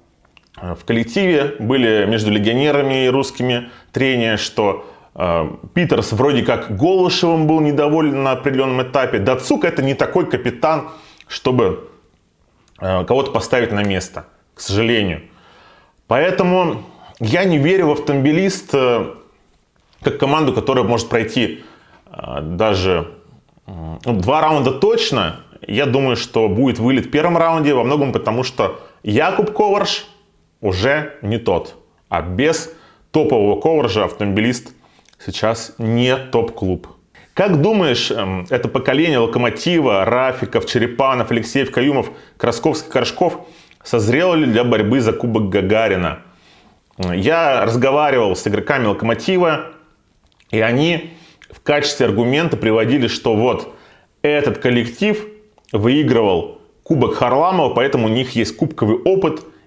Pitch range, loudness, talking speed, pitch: 110-155 Hz, -17 LUFS, 120 wpm, 130 Hz